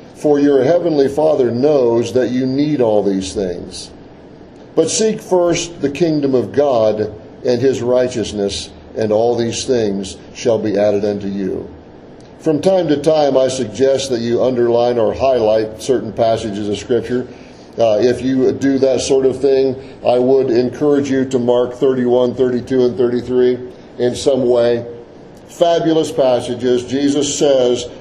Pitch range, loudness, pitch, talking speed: 115-135 Hz, -15 LUFS, 125 Hz, 150 wpm